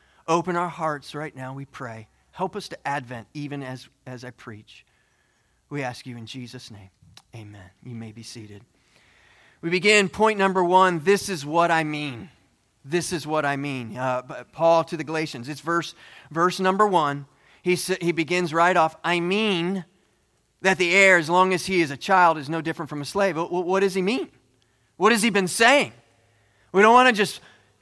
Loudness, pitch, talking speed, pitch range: -22 LUFS, 160 Hz, 195 wpm, 125-180 Hz